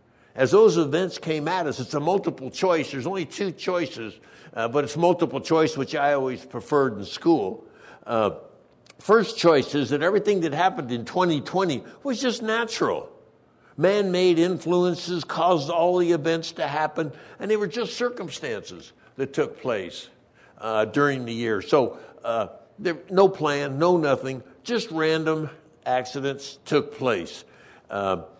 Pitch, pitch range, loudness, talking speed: 165 Hz, 140-190 Hz, -24 LUFS, 150 wpm